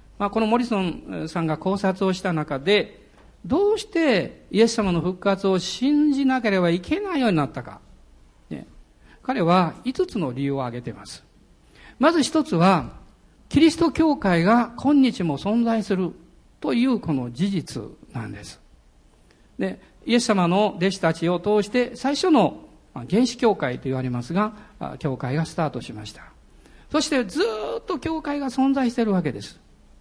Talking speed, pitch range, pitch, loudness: 295 characters per minute, 155-255 Hz, 195 Hz, -22 LUFS